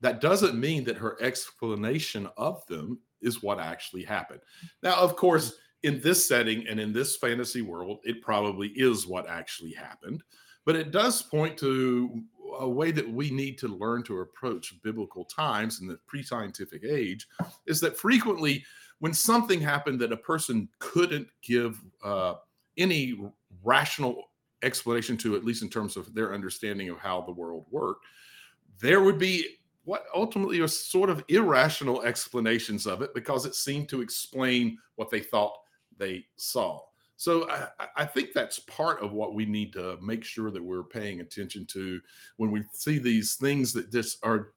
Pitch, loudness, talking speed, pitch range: 120 Hz, -29 LUFS, 170 wpm, 105-145 Hz